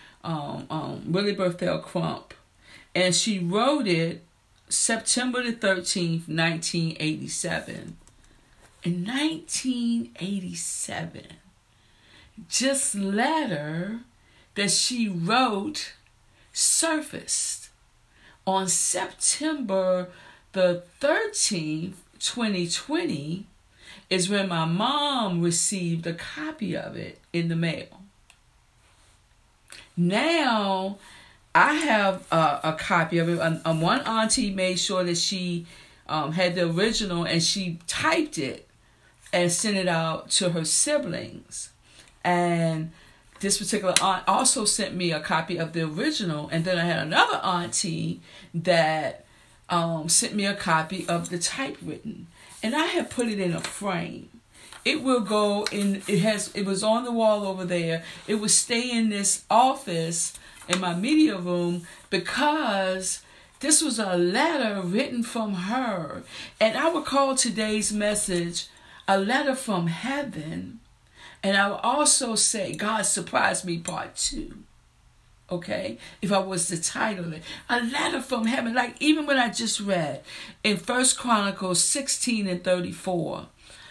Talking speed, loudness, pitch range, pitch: 130 wpm, -25 LUFS, 175-230 Hz, 195 Hz